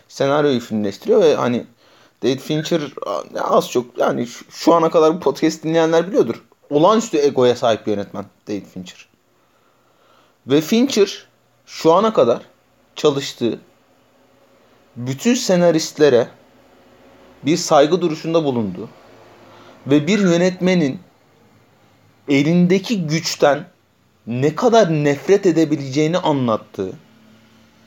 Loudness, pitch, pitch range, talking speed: -17 LUFS, 150 Hz, 120-170 Hz, 95 wpm